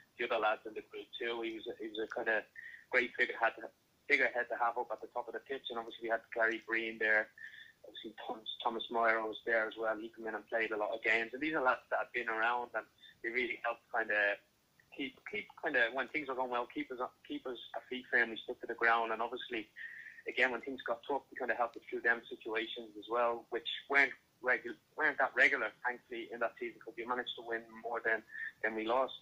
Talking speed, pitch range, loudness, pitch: 255 wpm, 110-125 Hz, -36 LUFS, 115 Hz